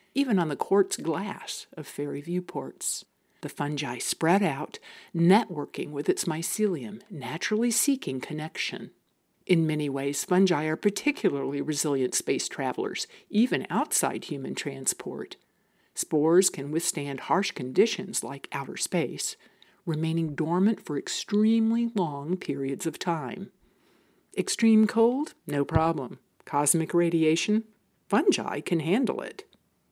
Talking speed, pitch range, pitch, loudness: 115 wpm, 150-205 Hz, 170 Hz, -27 LUFS